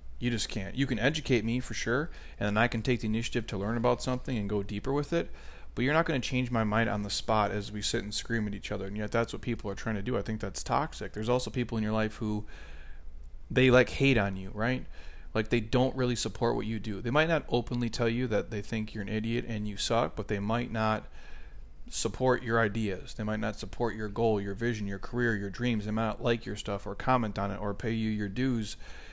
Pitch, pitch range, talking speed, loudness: 110 Hz, 105-120 Hz, 260 wpm, -31 LUFS